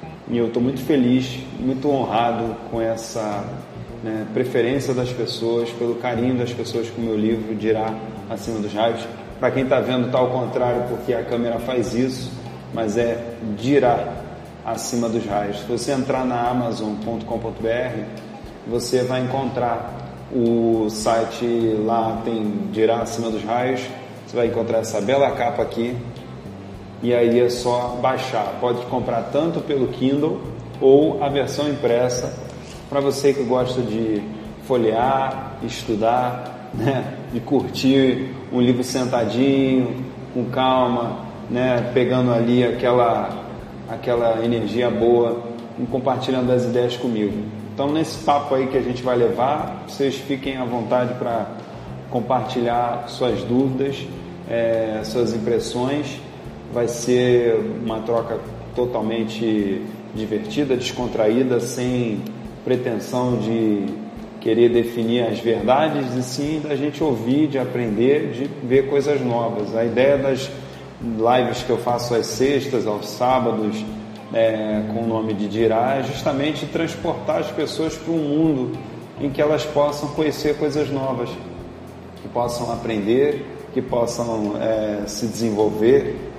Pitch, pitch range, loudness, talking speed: 120 Hz, 115-130 Hz, -21 LUFS, 135 wpm